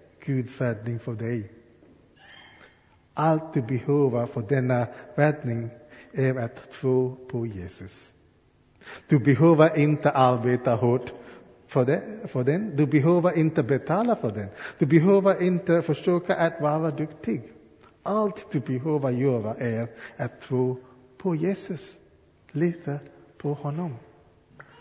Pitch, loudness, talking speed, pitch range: 135 Hz, -25 LUFS, 115 wpm, 120-160 Hz